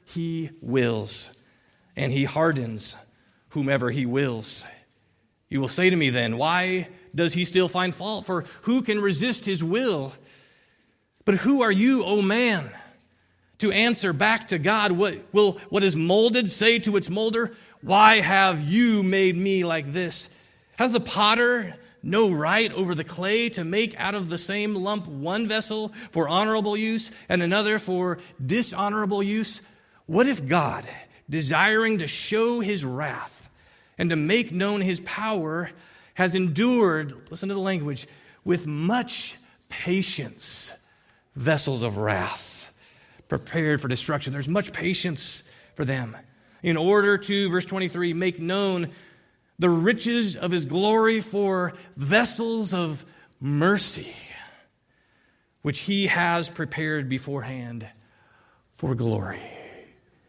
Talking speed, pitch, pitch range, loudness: 135 wpm, 180 Hz, 150-210 Hz, -24 LUFS